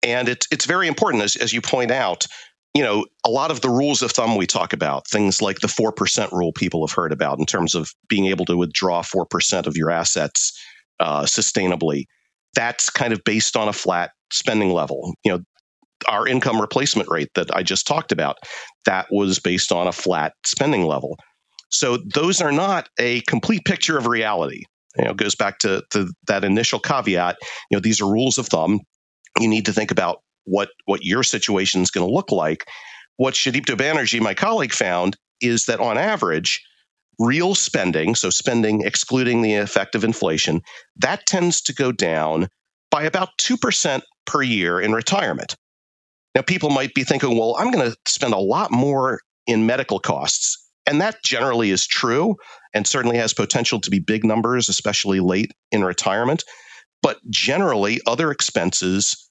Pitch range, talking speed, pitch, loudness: 95-130 Hz, 180 wpm, 110 Hz, -20 LUFS